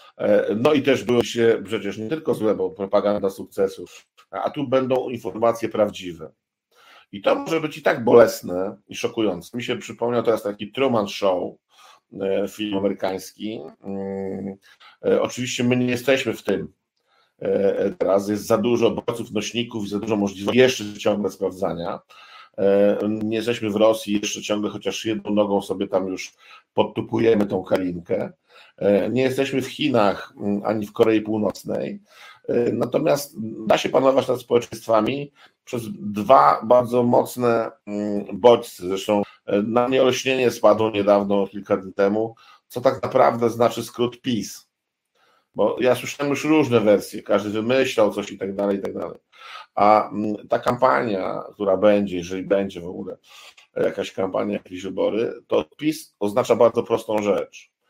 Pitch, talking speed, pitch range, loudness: 110 Hz, 140 wpm, 100-125 Hz, -21 LUFS